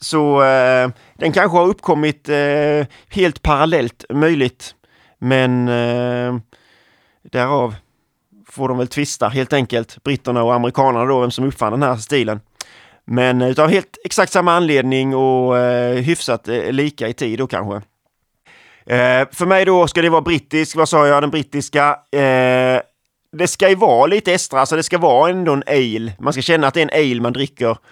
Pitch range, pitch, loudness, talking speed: 125-155 Hz, 135 Hz, -16 LUFS, 175 wpm